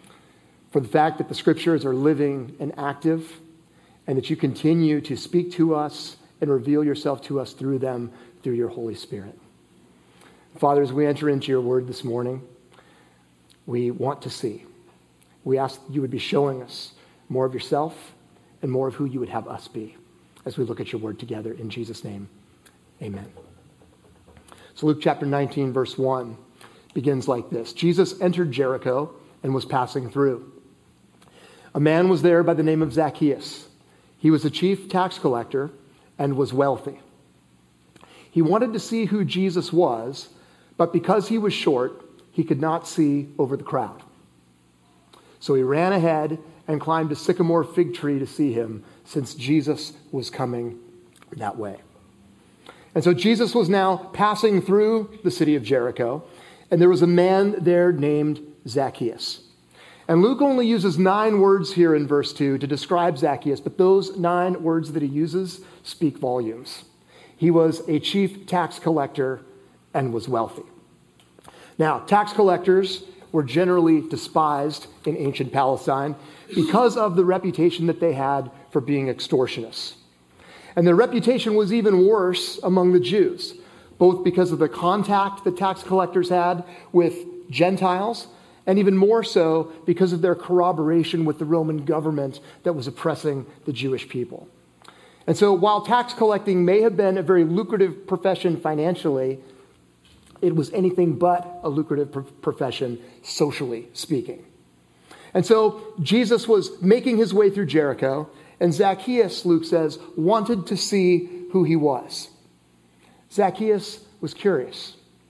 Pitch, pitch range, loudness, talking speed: 155 Hz, 135-180 Hz, -22 LUFS, 155 wpm